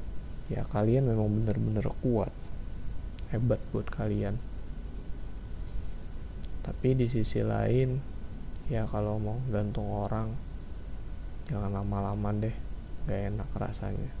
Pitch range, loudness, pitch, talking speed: 95-110 Hz, -32 LUFS, 105 Hz, 95 wpm